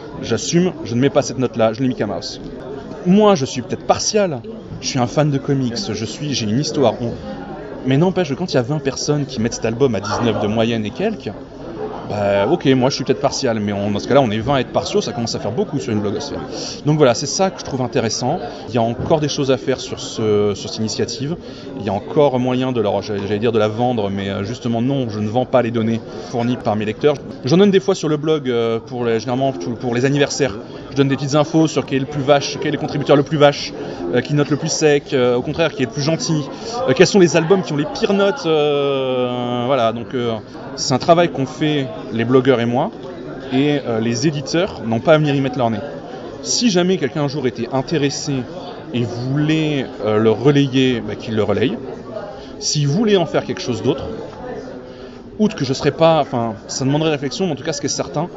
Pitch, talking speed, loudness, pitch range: 135 Hz, 245 wpm, -18 LUFS, 115-150 Hz